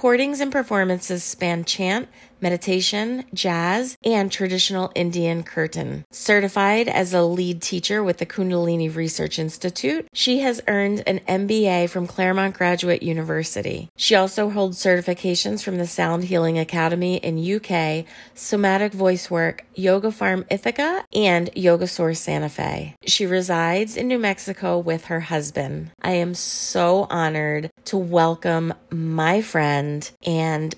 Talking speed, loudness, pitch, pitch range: 135 wpm, -21 LUFS, 180 Hz, 165-200 Hz